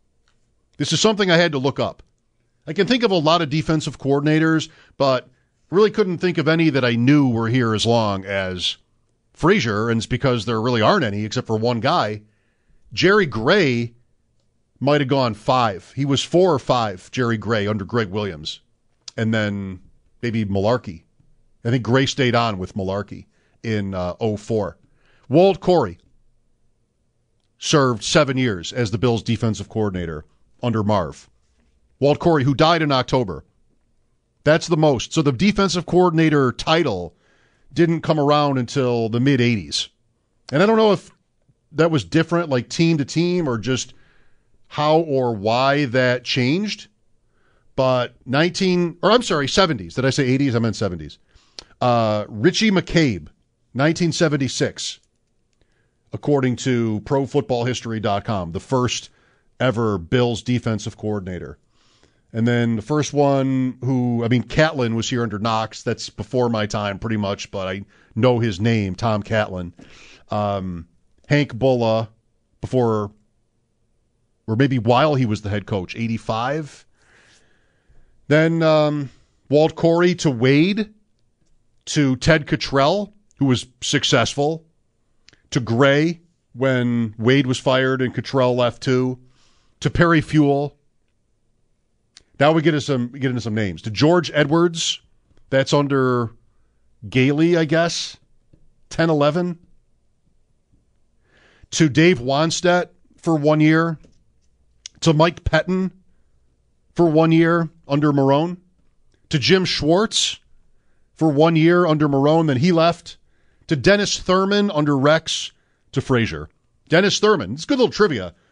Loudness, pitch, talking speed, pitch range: -19 LUFS, 125 Hz, 135 wpm, 115-155 Hz